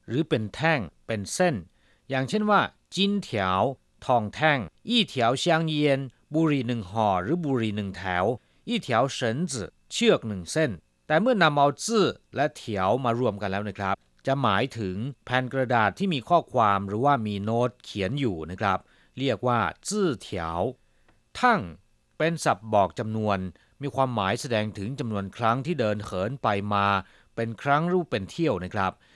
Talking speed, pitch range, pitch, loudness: 500 characters per minute, 100-150 Hz, 120 Hz, -26 LUFS